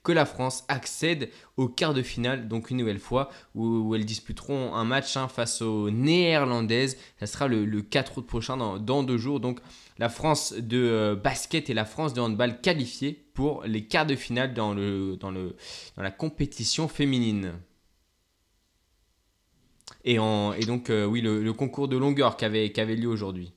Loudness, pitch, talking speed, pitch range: -27 LUFS, 120 Hz, 185 wpm, 110-135 Hz